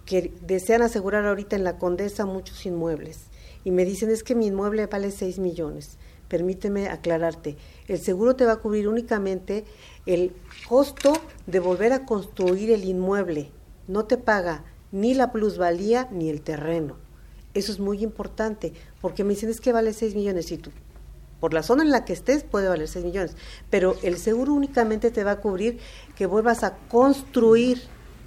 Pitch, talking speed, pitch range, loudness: 200 Hz, 175 wpm, 175-225 Hz, -24 LUFS